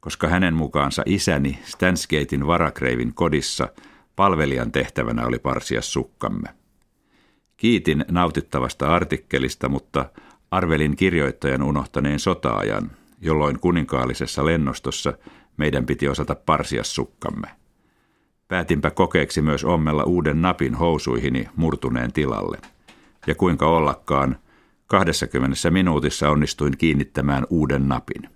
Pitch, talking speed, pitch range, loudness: 75 Hz, 95 wpm, 70-80 Hz, -22 LUFS